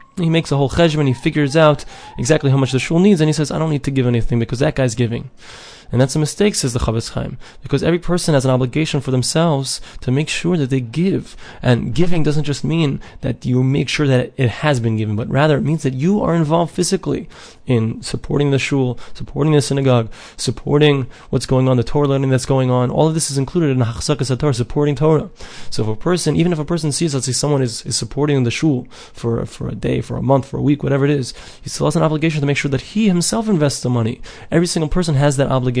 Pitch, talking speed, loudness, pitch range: 140 Hz, 255 wpm, -17 LUFS, 130-155 Hz